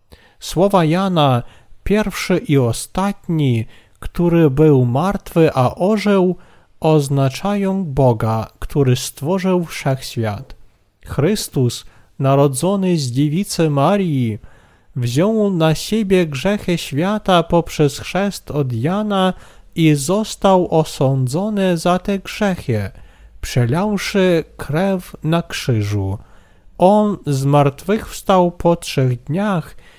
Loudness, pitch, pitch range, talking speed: -17 LUFS, 160 Hz, 130-190 Hz, 90 wpm